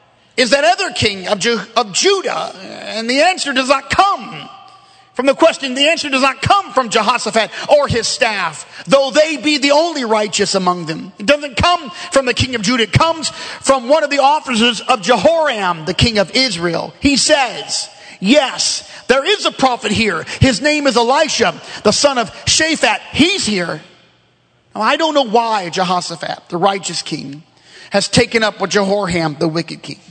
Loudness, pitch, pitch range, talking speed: -14 LUFS, 250 Hz, 205-295 Hz, 180 wpm